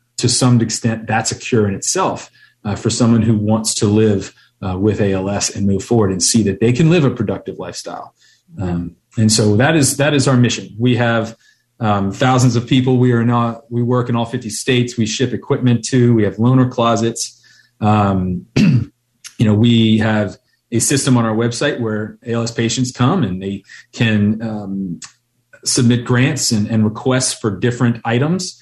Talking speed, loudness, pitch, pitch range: 185 wpm, -16 LUFS, 115 Hz, 105-125 Hz